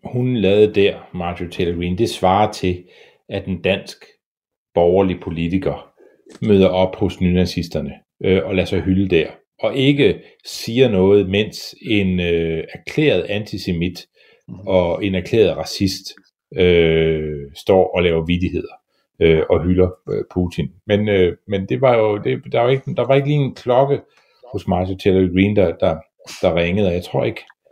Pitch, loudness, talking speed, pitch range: 95 Hz, -18 LUFS, 160 wpm, 90-105 Hz